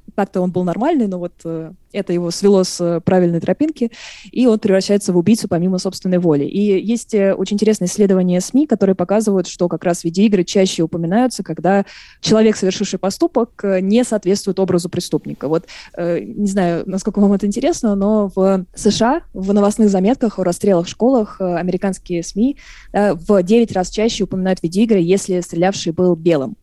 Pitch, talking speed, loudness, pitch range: 195 Hz, 165 wpm, -16 LUFS, 180-210 Hz